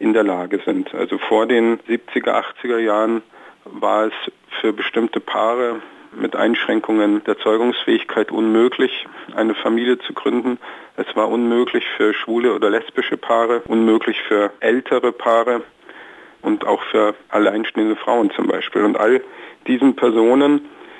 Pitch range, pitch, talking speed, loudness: 110-125 Hz, 115 Hz, 135 wpm, -18 LUFS